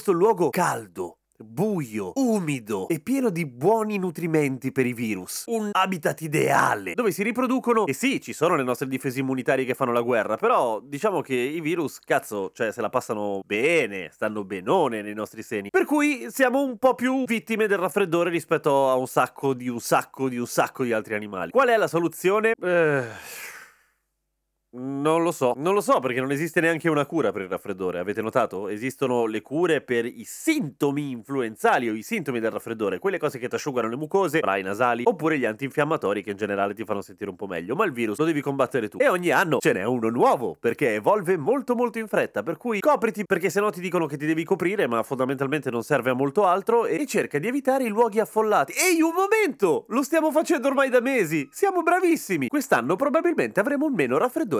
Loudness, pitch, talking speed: -24 LUFS, 165 Hz, 205 wpm